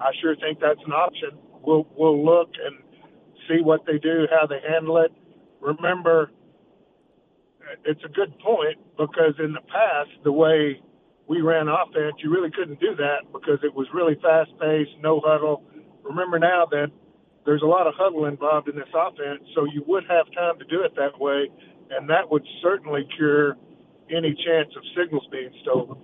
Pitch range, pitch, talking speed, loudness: 150-165 Hz, 155 Hz, 180 wpm, -22 LUFS